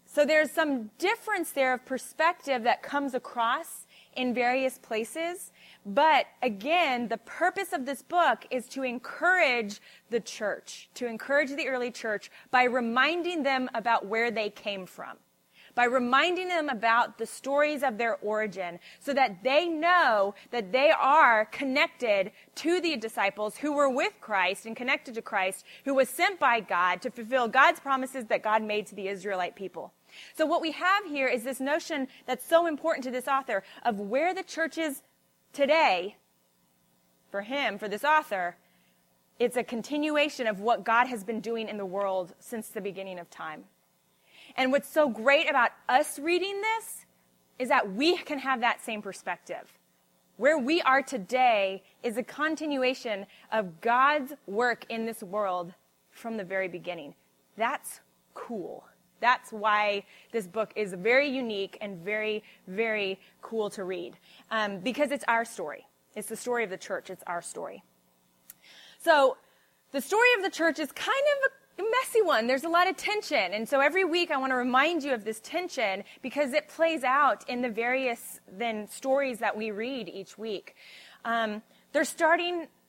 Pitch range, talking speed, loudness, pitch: 210-295 Hz, 170 wpm, -28 LUFS, 250 Hz